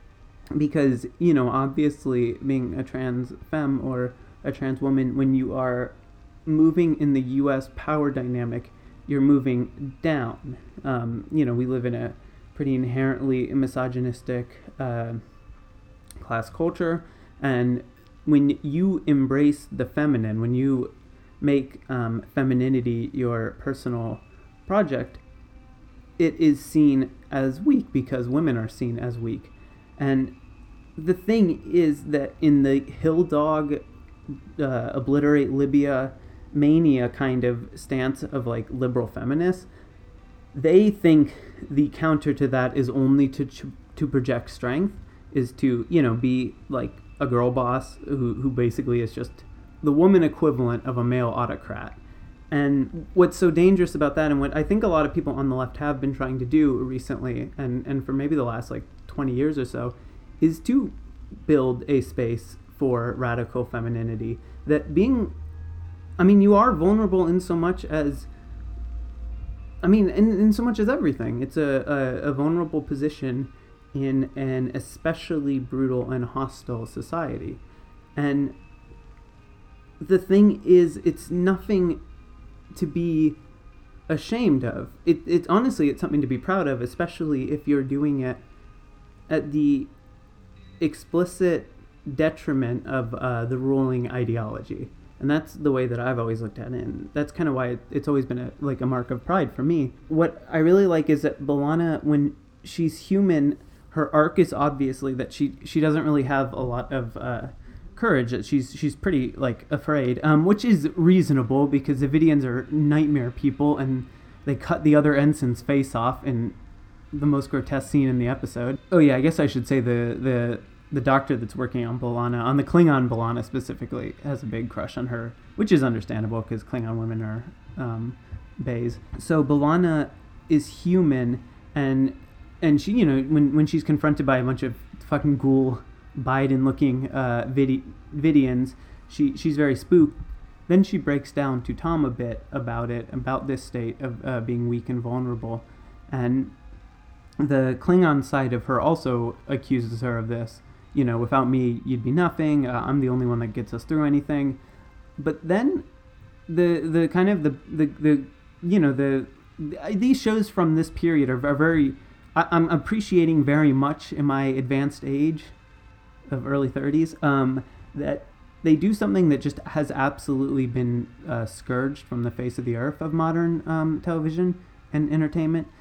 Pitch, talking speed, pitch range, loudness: 135 Hz, 160 wpm, 120-150 Hz, -23 LUFS